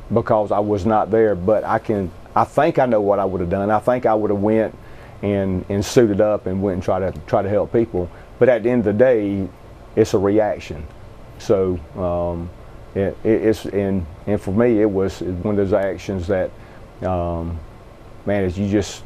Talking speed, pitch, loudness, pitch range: 205 wpm, 100 Hz, -19 LUFS, 95-110 Hz